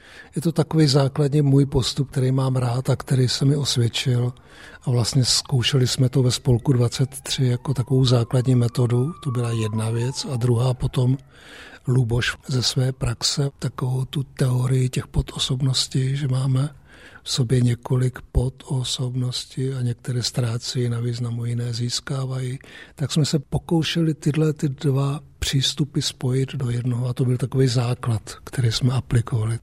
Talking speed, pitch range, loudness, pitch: 150 wpm, 125-140 Hz, -22 LUFS, 130 Hz